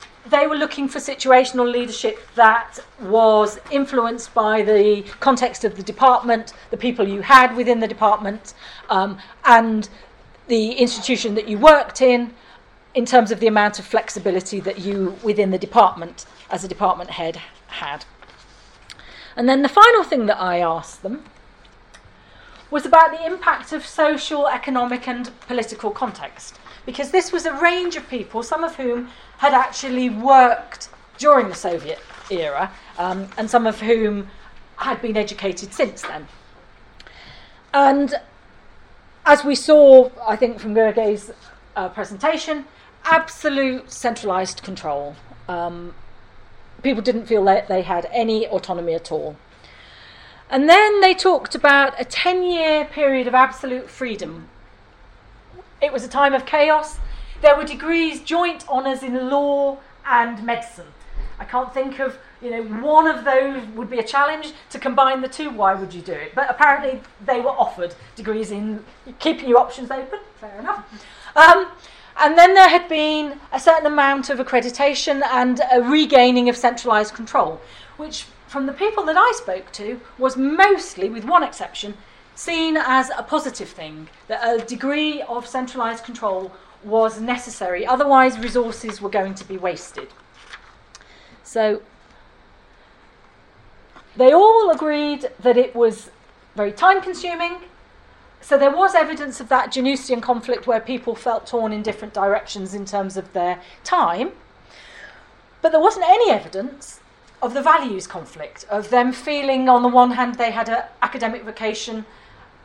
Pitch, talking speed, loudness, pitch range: 245 Hz, 150 wpm, -18 LUFS, 210-280 Hz